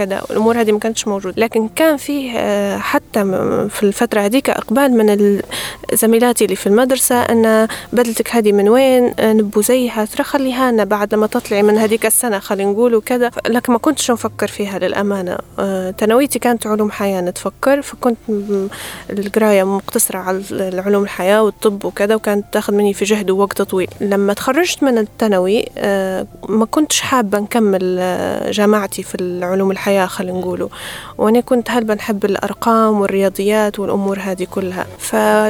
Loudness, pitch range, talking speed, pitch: -15 LUFS, 200-235 Hz, 155 wpm, 215 Hz